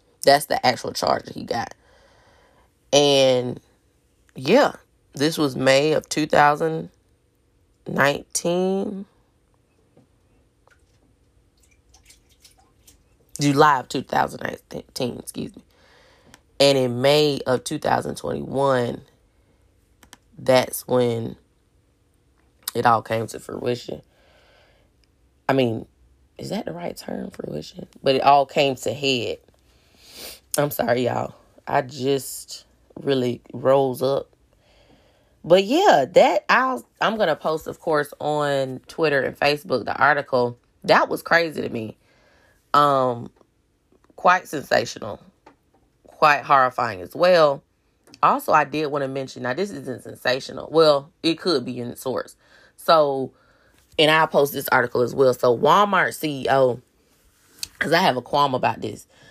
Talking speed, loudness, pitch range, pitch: 115 wpm, -21 LUFS, 120-150 Hz, 135 Hz